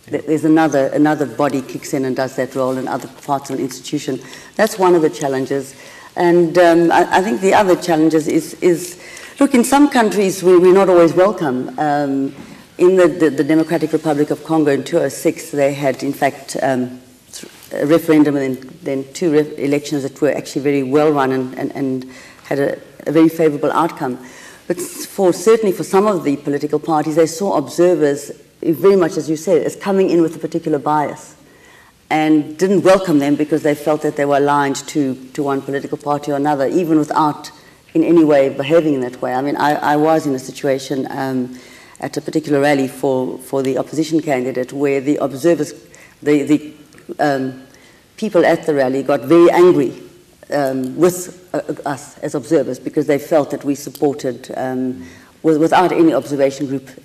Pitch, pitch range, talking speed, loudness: 150 Hz, 135-165 Hz, 185 wpm, -16 LUFS